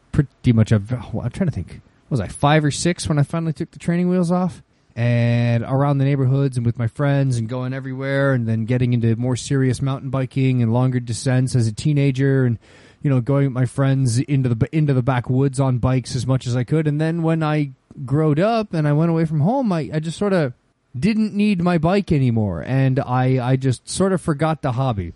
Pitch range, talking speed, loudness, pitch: 125-155 Hz, 230 wpm, -20 LUFS, 135 Hz